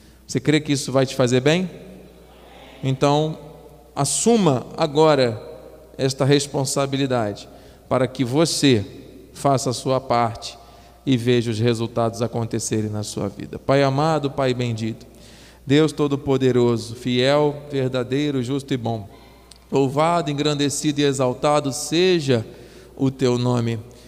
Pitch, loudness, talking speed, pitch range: 135 Hz, -21 LUFS, 115 wpm, 120-145 Hz